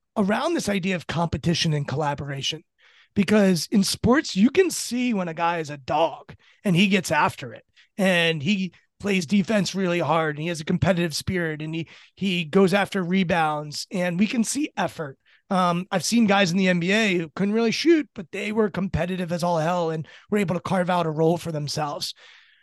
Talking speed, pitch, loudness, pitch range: 200 wpm, 185 Hz, -23 LUFS, 165-205 Hz